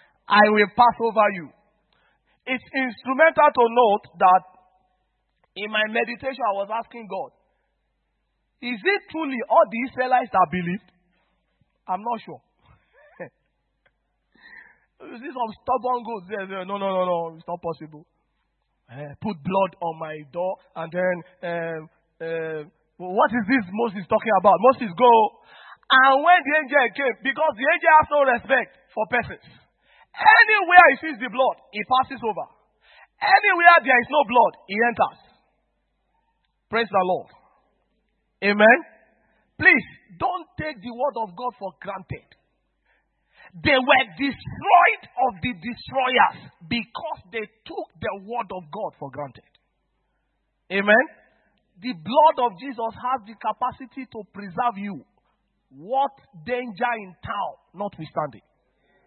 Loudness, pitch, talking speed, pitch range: -20 LUFS, 230 Hz, 135 wpm, 190-265 Hz